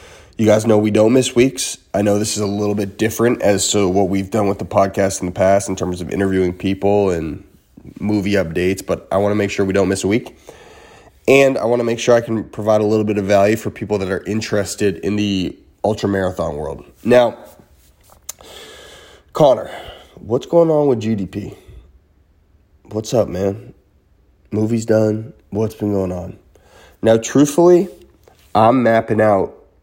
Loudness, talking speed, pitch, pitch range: -17 LUFS, 185 wpm, 100 Hz, 95-110 Hz